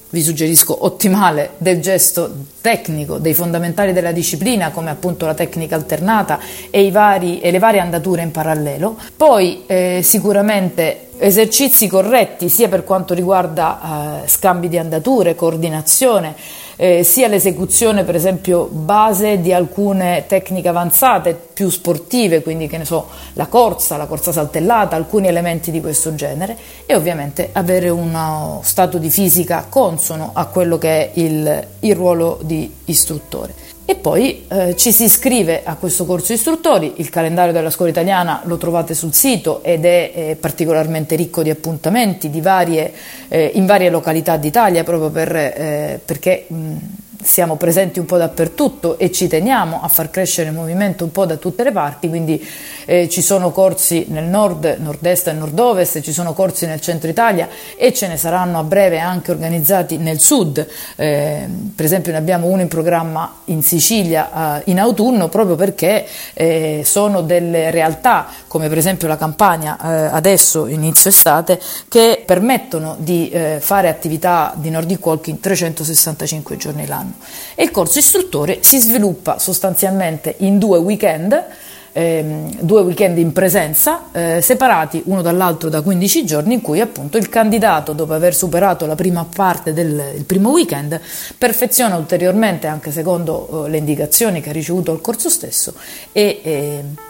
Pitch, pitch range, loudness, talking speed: 175 Hz, 160-195 Hz, -14 LUFS, 160 wpm